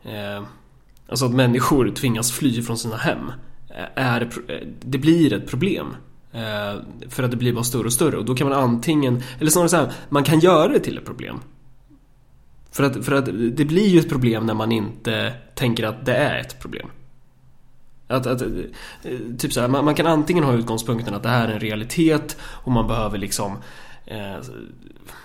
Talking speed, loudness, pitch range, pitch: 185 wpm, -20 LUFS, 115-140 Hz, 125 Hz